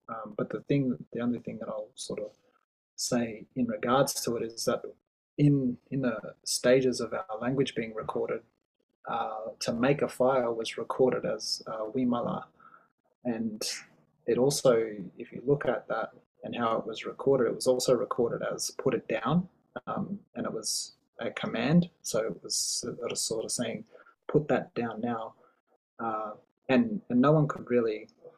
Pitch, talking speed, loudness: 145 Hz, 180 wpm, -30 LUFS